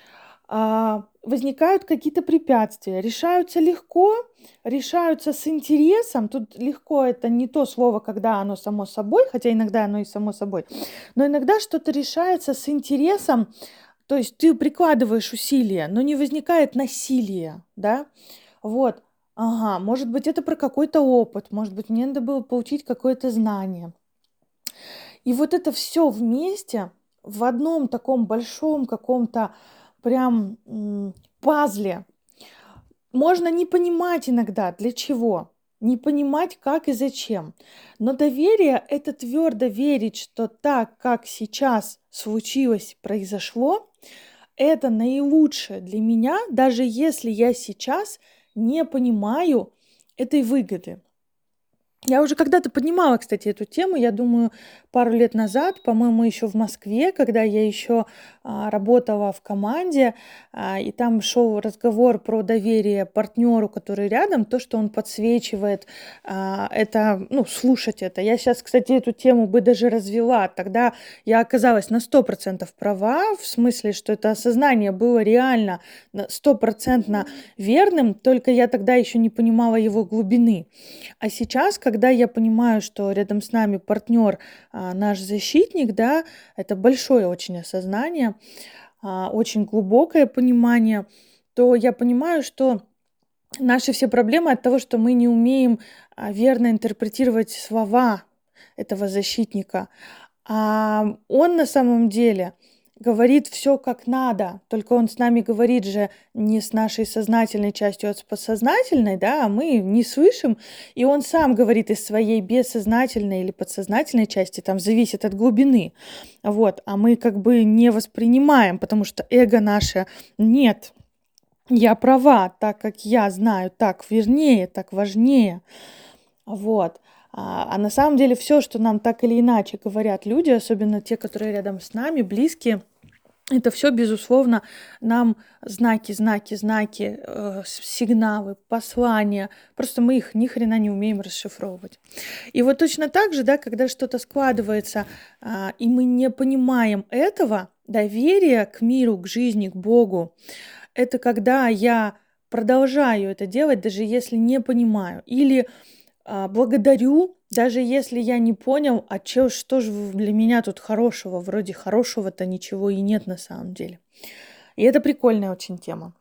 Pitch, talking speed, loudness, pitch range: 235 Hz, 135 wpm, -20 LUFS, 215-265 Hz